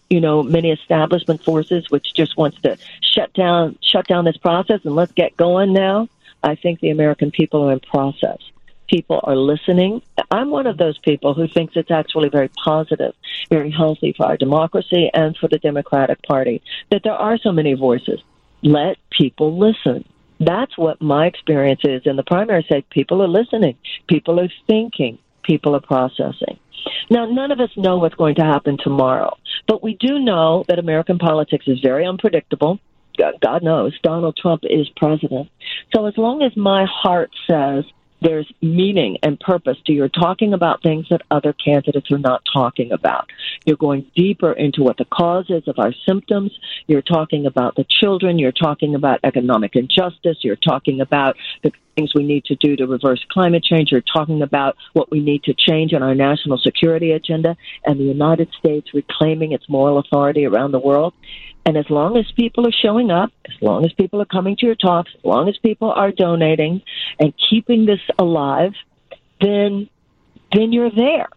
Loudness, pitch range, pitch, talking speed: -17 LUFS, 145-185 Hz, 160 Hz, 185 wpm